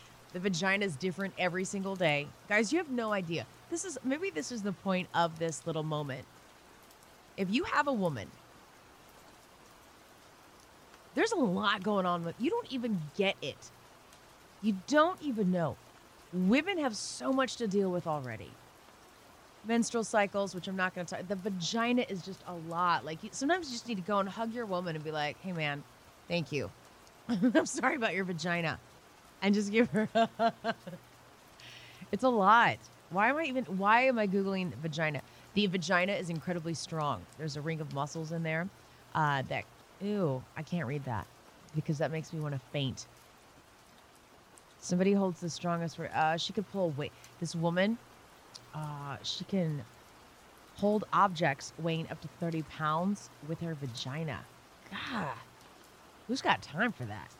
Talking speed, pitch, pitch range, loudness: 170 wpm, 180 Hz, 160-210 Hz, -33 LUFS